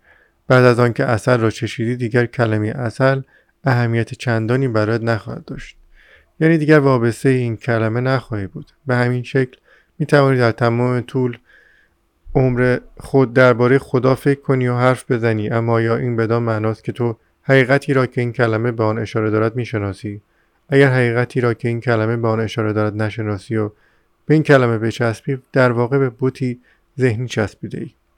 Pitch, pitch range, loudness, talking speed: 120 Hz, 115-130 Hz, -17 LUFS, 165 wpm